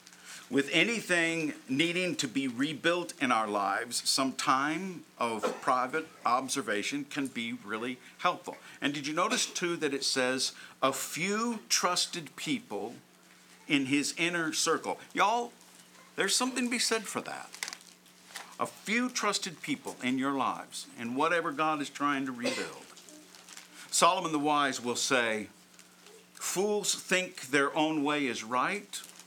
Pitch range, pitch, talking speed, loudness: 130-190 Hz, 155 Hz, 140 wpm, -30 LUFS